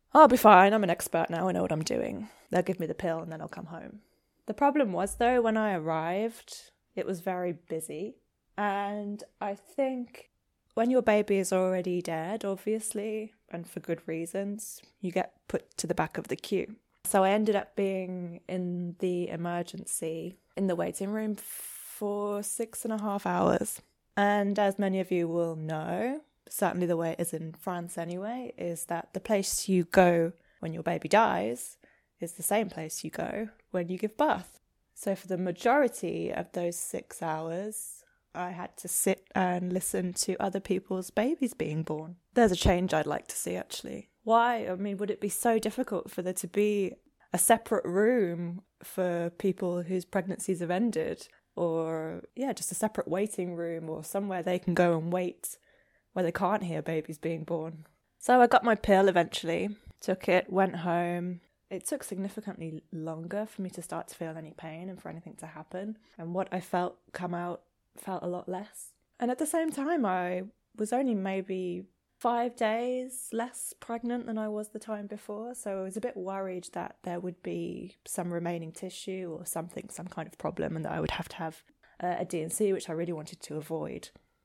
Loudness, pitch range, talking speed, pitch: -30 LUFS, 175-215 Hz, 190 wpm, 185 Hz